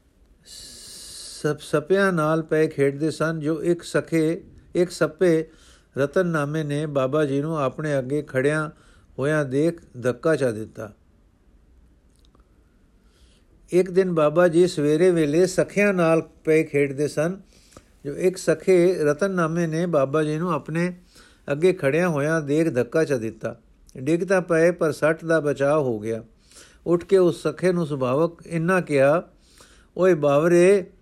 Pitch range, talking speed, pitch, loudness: 140-170 Hz, 135 wpm, 155 Hz, -22 LUFS